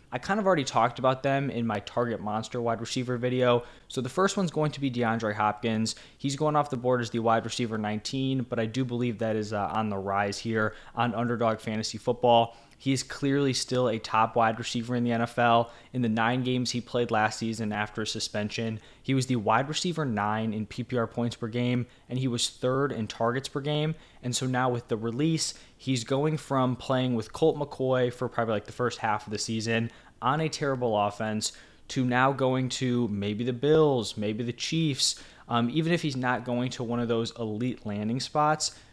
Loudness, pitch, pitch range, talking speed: -28 LUFS, 120 Hz, 115-130 Hz, 215 wpm